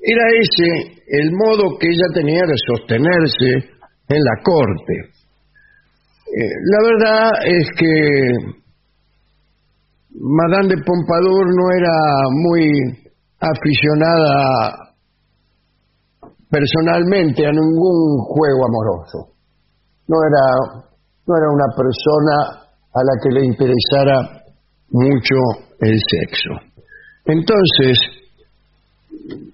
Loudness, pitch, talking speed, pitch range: -15 LUFS, 155 Hz, 90 wpm, 135-175 Hz